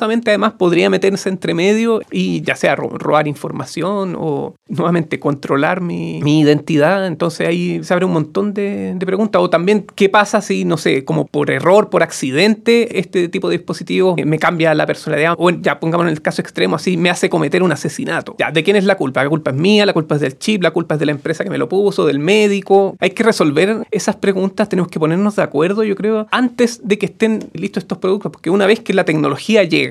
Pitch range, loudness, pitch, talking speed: 165-205 Hz, -15 LUFS, 185 Hz, 225 wpm